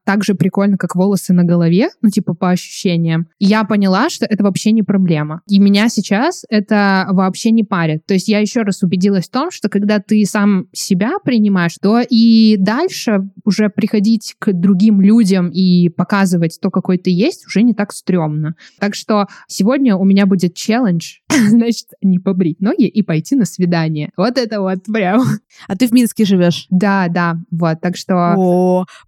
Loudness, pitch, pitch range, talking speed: -14 LUFS, 200 Hz, 180-215 Hz, 175 wpm